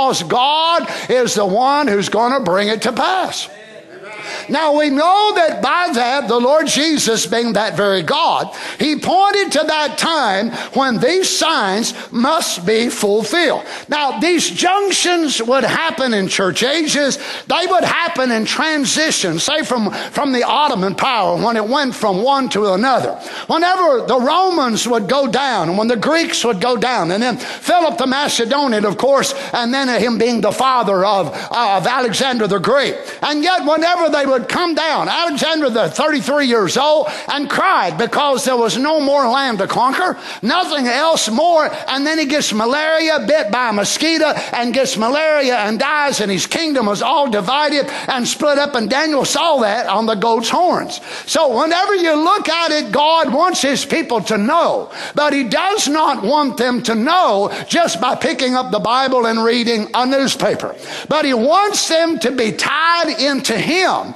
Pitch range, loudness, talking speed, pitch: 235-315 Hz, -15 LUFS, 175 wpm, 275 Hz